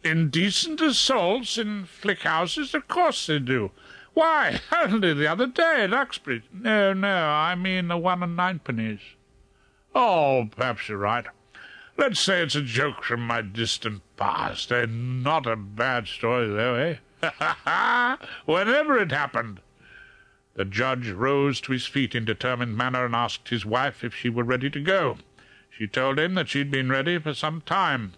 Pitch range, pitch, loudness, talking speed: 120-190 Hz, 145 Hz, -24 LUFS, 165 wpm